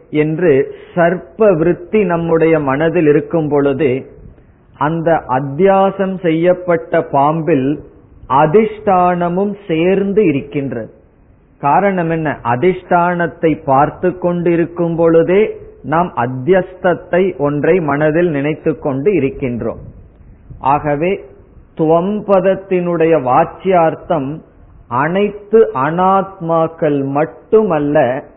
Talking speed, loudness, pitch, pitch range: 70 wpm, -14 LUFS, 165 Hz, 145-185 Hz